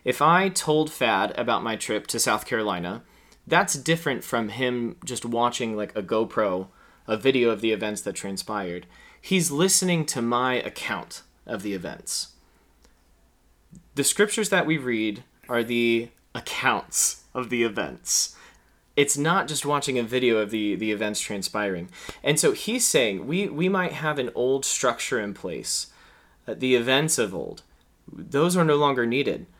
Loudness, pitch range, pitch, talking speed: -24 LUFS, 110-155 Hz, 125 Hz, 160 wpm